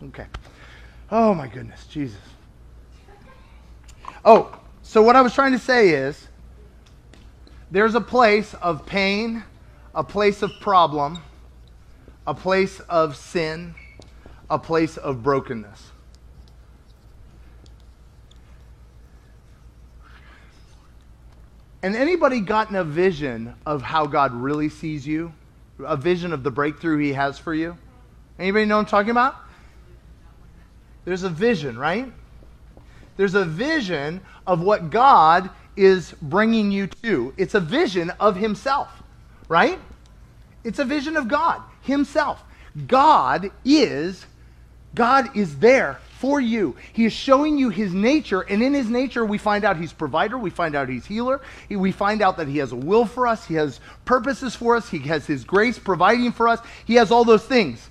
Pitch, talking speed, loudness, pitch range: 175 Hz, 145 wpm, -20 LUFS, 130-220 Hz